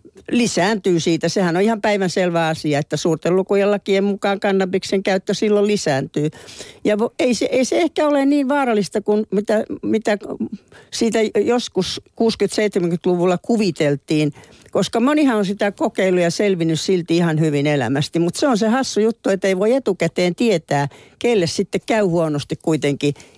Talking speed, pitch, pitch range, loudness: 150 wpm, 195 Hz, 165-215 Hz, -18 LUFS